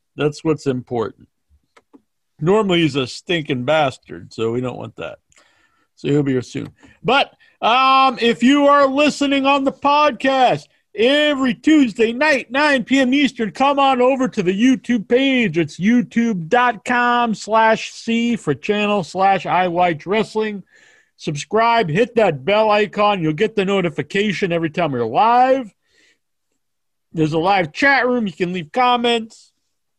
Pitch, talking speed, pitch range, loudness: 220 Hz, 140 wpm, 170-260 Hz, -17 LUFS